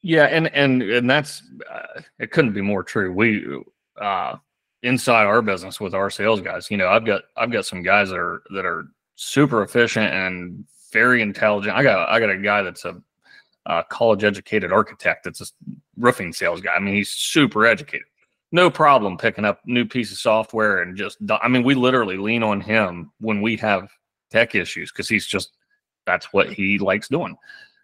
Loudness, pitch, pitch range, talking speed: -19 LUFS, 110 Hz, 105-130 Hz, 190 wpm